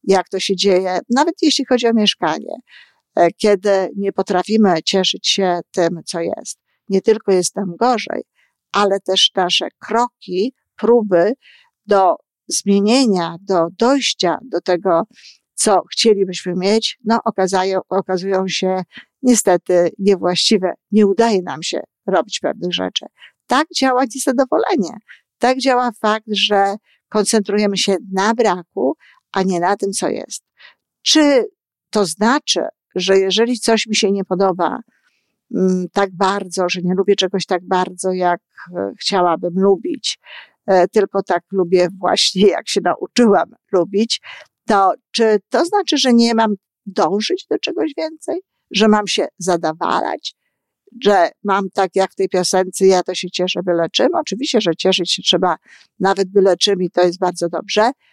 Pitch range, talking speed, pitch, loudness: 185-225 Hz, 140 wpm, 195 Hz, -16 LUFS